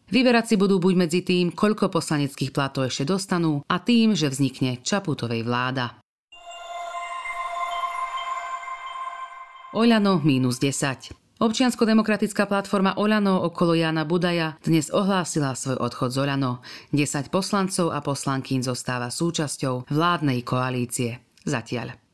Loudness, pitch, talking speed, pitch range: -24 LUFS, 170 Hz, 105 wpm, 135-220 Hz